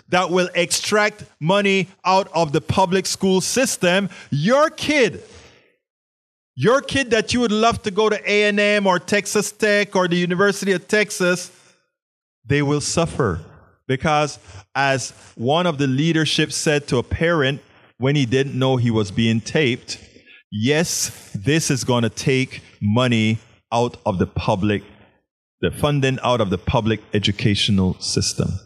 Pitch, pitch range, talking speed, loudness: 150 Hz, 115-190 Hz, 145 wpm, -19 LUFS